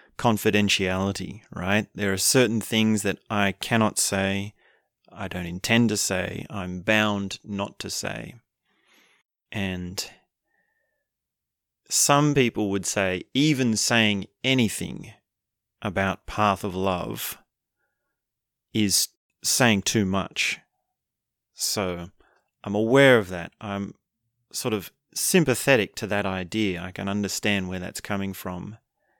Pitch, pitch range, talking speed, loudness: 100 Hz, 95-110 Hz, 115 wpm, -24 LUFS